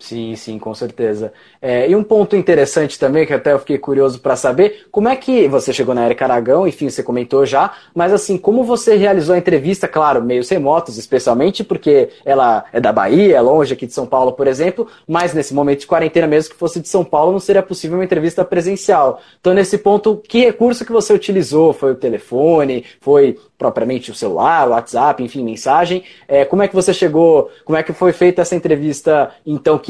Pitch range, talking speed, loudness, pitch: 145-200 Hz, 205 wpm, -14 LUFS, 175 Hz